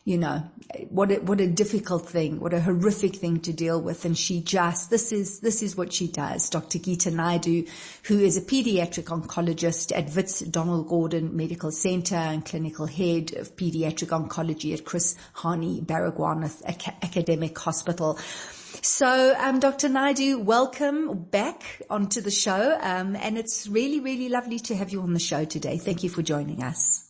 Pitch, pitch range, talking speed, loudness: 175 Hz, 165-210 Hz, 175 wpm, -26 LUFS